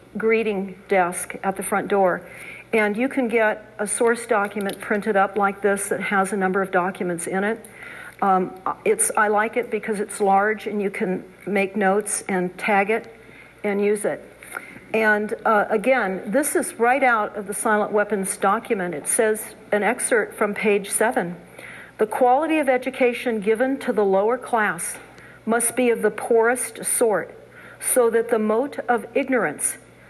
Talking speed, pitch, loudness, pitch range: 165 wpm, 215 Hz, -22 LUFS, 200-235 Hz